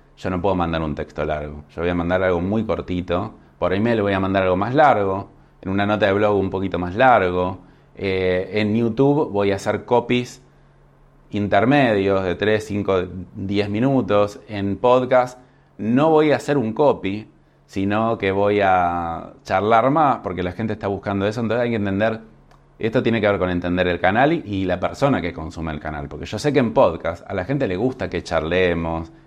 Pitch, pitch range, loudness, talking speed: 100 Hz, 90-110 Hz, -20 LUFS, 200 wpm